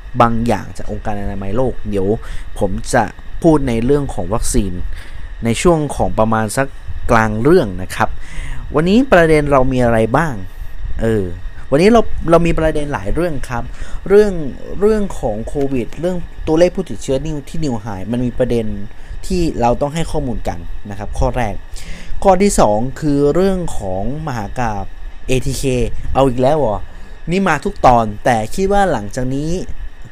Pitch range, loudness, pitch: 105-155 Hz, -16 LUFS, 125 Hz